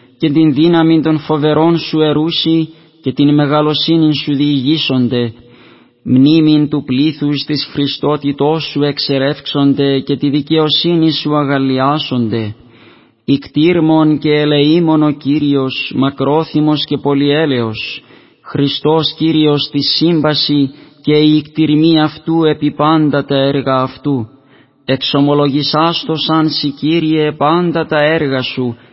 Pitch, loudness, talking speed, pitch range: 150 Hz, -13 LUFS, 110 wpm, 140-155 Hz